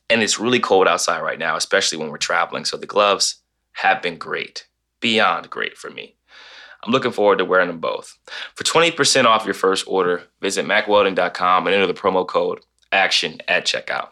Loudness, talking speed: -18 LUFS, 185 wpm